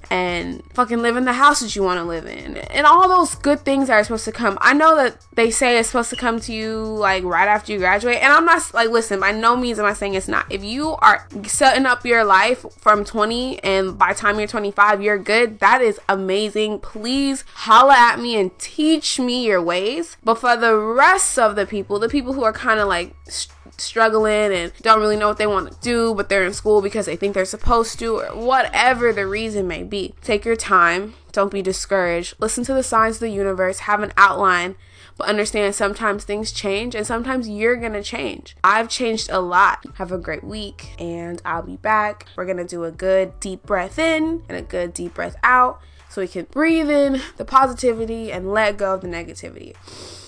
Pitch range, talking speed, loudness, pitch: 190-240 Hz, 220 wpm, -18 LUFS, 215 Hz